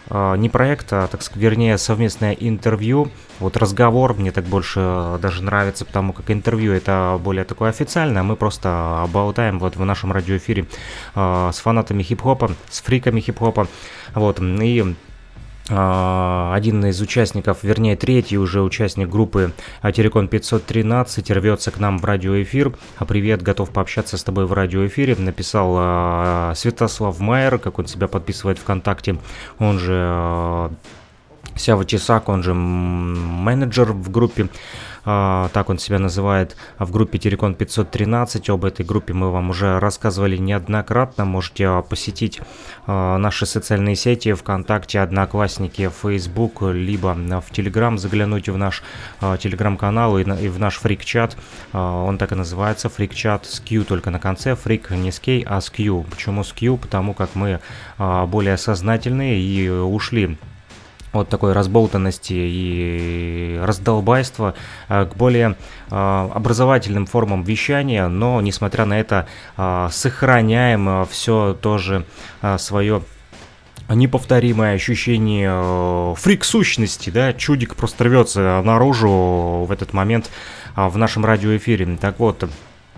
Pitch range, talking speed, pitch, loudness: 95-115 Hz, 125 wpm, 100 Hz, -19 LUFS